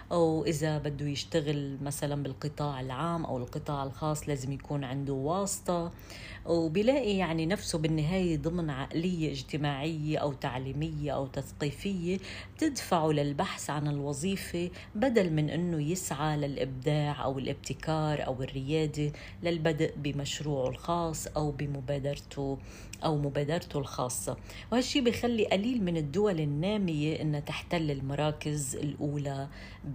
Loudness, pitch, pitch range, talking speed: -32 LUFS, 150 Hz, 140-170 Hz, 110 wpm